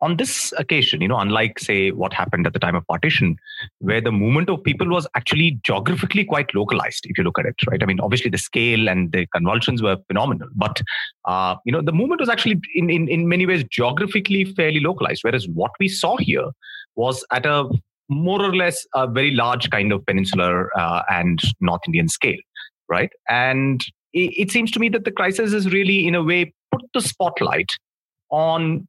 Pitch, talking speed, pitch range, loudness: 160 Hz, 200 wpm, 120-185 Hz, -19 LUFS